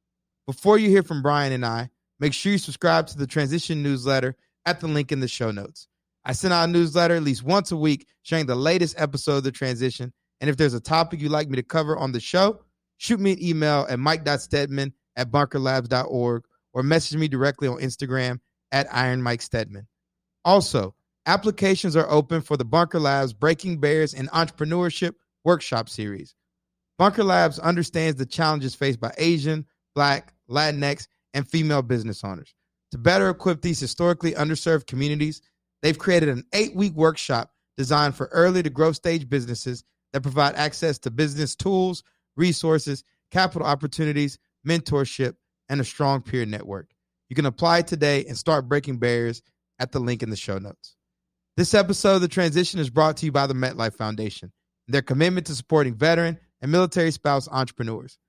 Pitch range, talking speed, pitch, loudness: 130-165 Hz, 175 wpm, 145 Hz, -23 LUFS